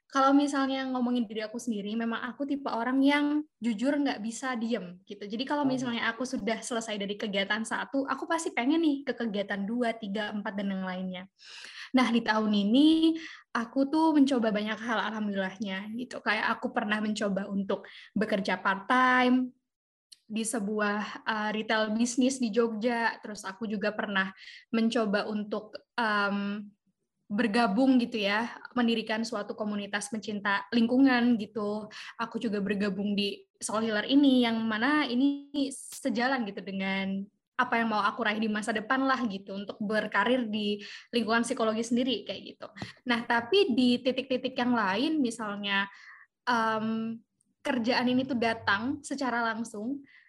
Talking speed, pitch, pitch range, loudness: 150 wpm, 230 Hz, 210-255 Hz, -29 LUFS